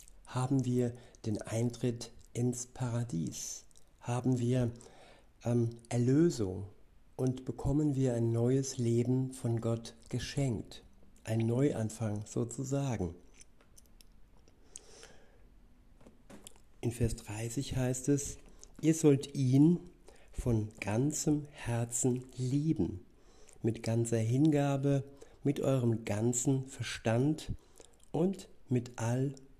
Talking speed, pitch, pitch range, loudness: 90 wpm, 125 Hz, 115-135 Hz, -33 LUFS